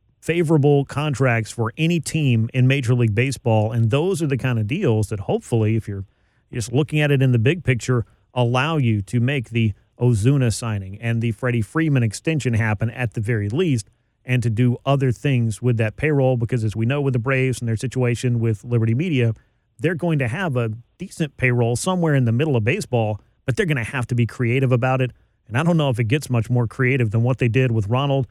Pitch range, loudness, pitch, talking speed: 115-135 Hz, -20 LUFS, 125 Hz, 225 wpm